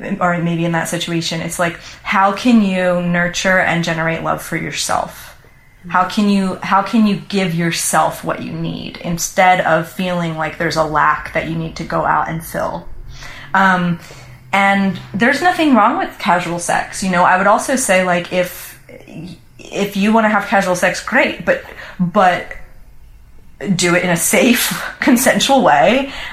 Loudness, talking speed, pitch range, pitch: -15 LUFS, 170 wpm, 170-195 Hz, 180 Hz